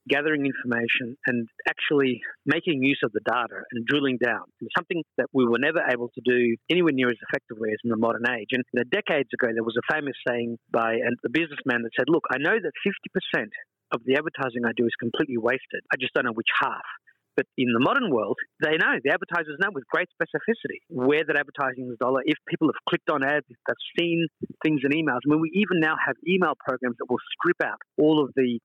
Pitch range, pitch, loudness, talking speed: 120-155 Hz, 135 Hz, -25 LUFS, 220 wpm